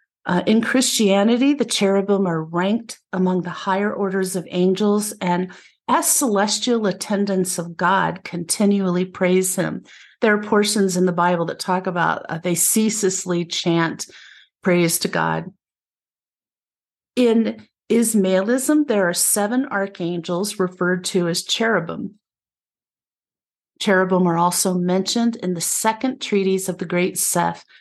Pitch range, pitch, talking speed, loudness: 180-210 Hz, 190 Hz, 130 wpm, -19 LUFS